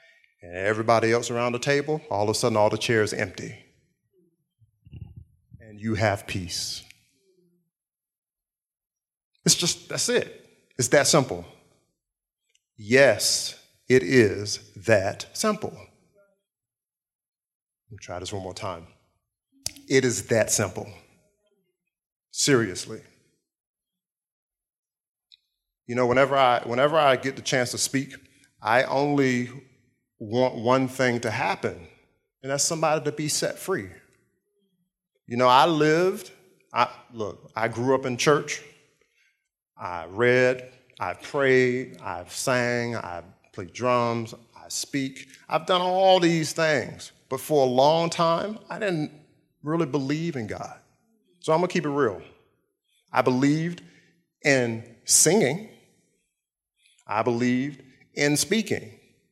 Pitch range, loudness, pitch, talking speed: 115-160 Hz, -24 LUFS, 130 Hz, 120 wpm